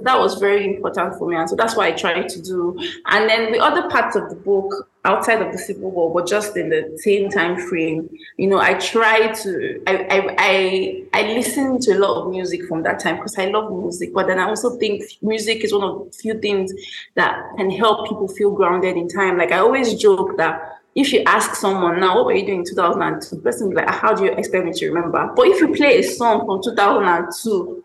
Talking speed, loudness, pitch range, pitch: 250 wpm, -18 LUFS, 185-220 Hz, 200 Hz